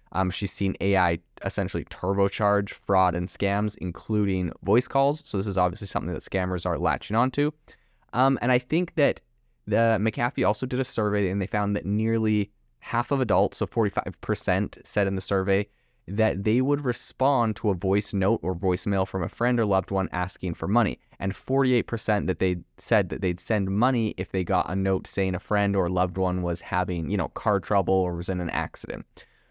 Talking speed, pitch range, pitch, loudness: 200 wpm, 95-110 Hz, 100 Hz, -26 LUFS